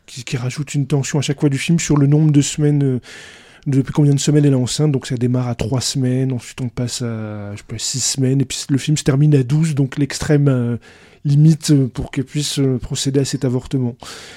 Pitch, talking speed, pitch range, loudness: 135 Hz, 240 wpm, 125-150 Hz, -17 LUFS